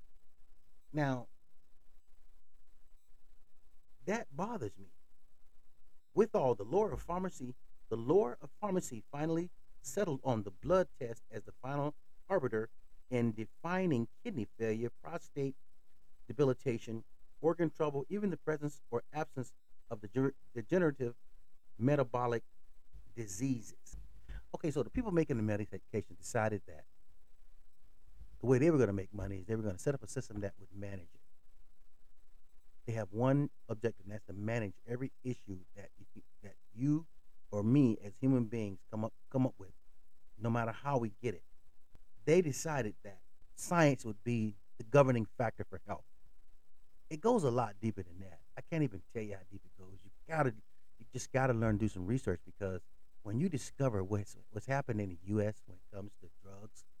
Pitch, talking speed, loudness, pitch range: 110 Hz, 160 wpm, -37 LUFS, 95-130 Hz